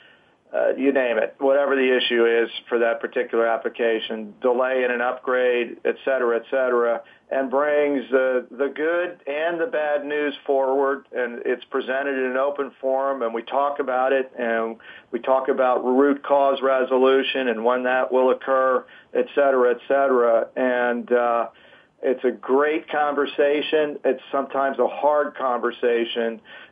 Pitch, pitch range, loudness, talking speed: 130 Hz, 120-140 Hz, -22 LUFS, 155 wpm